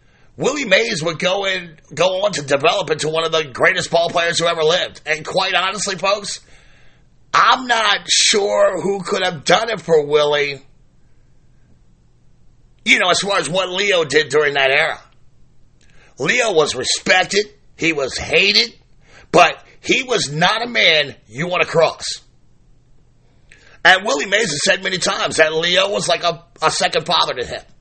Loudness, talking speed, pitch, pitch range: -16 LUFS, 165 wpm, 175 Hz, 155-195 Hz